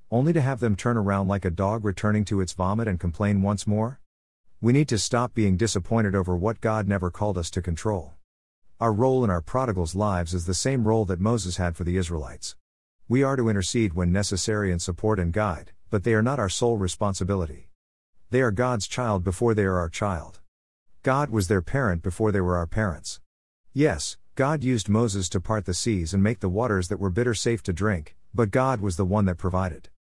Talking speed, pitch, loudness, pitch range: 215 wpm, 100 Hz, -25 LUFS, 90-115 Hz